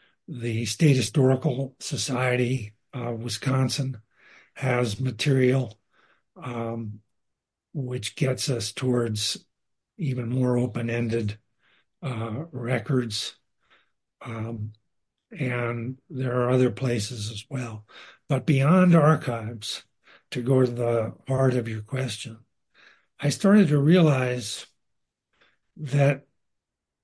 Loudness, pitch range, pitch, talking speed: -25 LUFS, 115-135 Hz, 125 Hz, 95 wpm